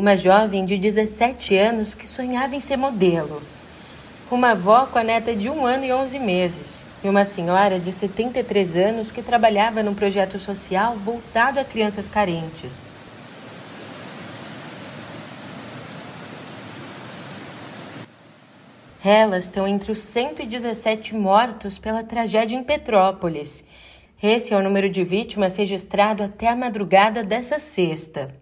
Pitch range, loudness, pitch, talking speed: 190-235 Hz, -20 LUFS, 210 Hz, 120 wpm